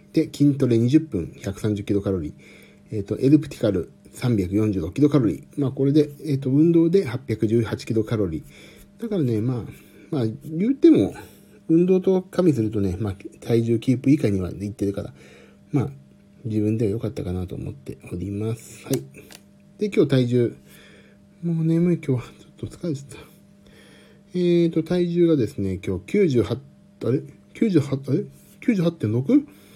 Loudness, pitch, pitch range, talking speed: -22 LUFS, 125 Hz, 105-160 Hz, 265 characters per minute